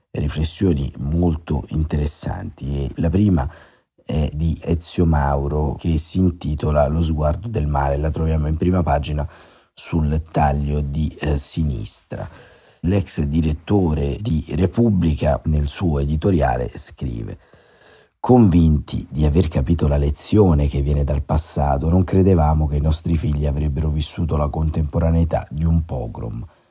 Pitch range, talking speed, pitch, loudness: 75-85 Hz, 130 wpm, 80 Hz, -20 LUFS